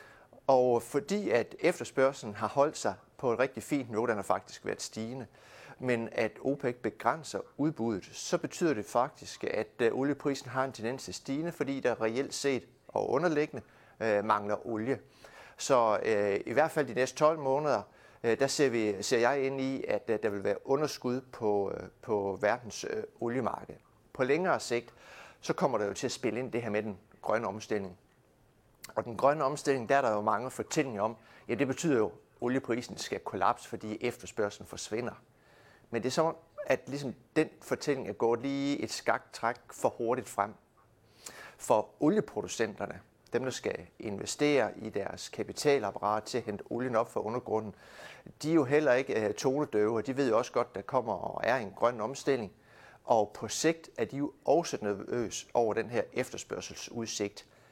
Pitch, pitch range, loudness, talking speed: 125 Hz, 110-140 Hz, -32 LUFS, 180 wpm